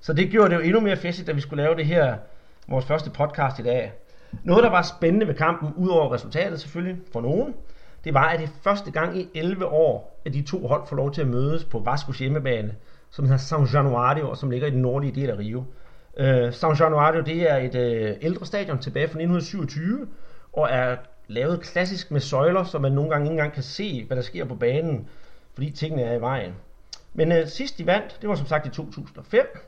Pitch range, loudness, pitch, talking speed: 130-170 Hz, -24 LUFS, 155 Hz, 225 wpm